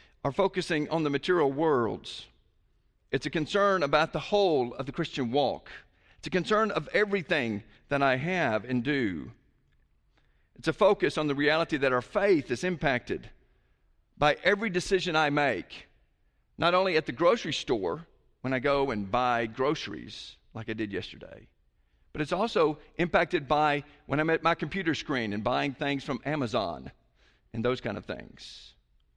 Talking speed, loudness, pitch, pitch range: 165 wpm, -28 LUFS, 145 Hz, 115-165 Hz